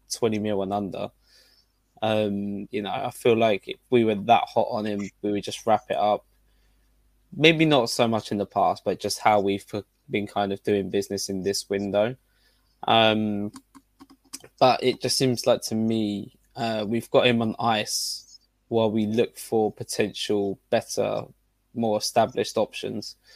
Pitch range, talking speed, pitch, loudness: 100-115 Hz, 165 wpm, 110 Hz, -24 LUFS